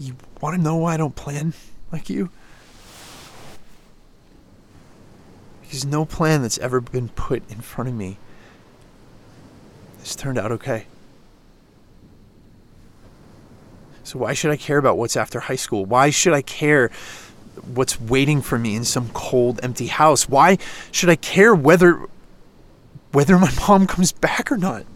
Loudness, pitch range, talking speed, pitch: -19 LUFS, 115-155 Hz, 145 wpm, 130 Hz